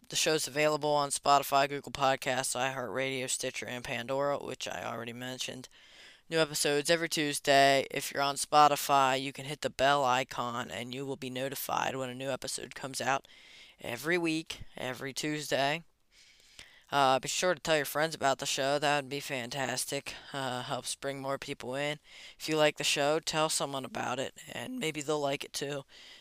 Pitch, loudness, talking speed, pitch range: 140 Hz, -31 LUFS, 180 wpm, 130-150 Hz